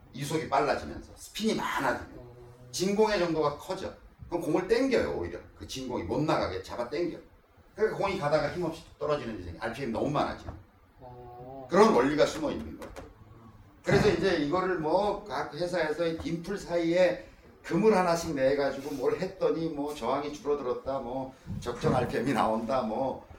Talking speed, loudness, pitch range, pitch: 350 characters per minute, -29 LUFS, 125-175 Hz, 150 Hz